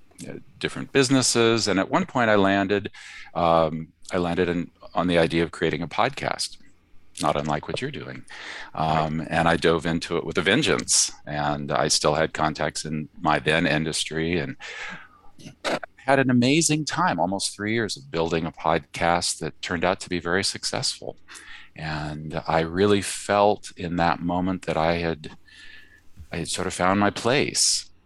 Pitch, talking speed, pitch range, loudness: 85 Hz, 165 wpm, 80-100 Hz, -23 LUFS